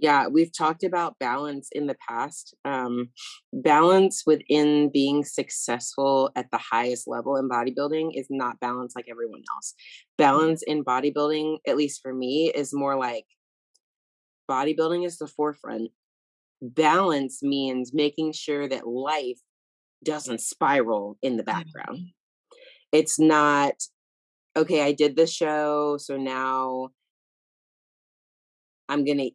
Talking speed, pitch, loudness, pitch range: 125 wpm, 145 Hz, -25 LUFS, 125-155 Hz